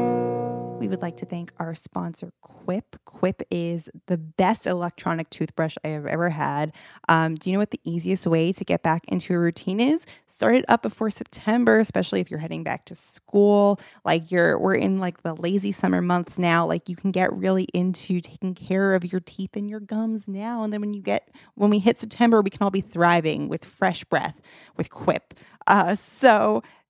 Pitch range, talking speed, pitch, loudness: 165-205 Hz, 205 wpm, 180 Hz, -24 LUFS